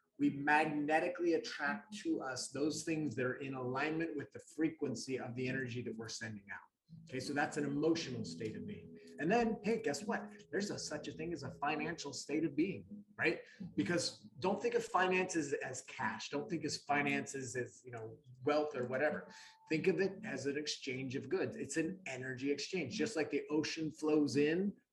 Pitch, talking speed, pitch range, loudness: 150 Hz, 195 wpm, 130-165 Hz, -38 LUFS